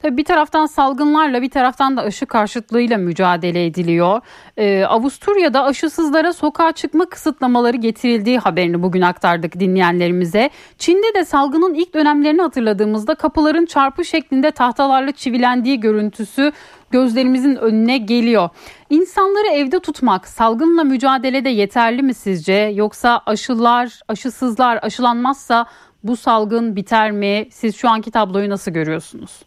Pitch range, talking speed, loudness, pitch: 215-295 Hz, 120 wpm, -16 LUFS, 245 Hz